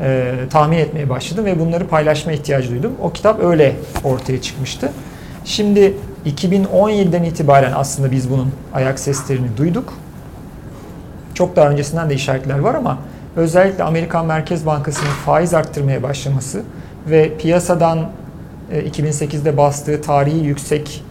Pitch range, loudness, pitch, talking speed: 135-165 Hz, -16 LUFS, 150 Hz, 120 wpm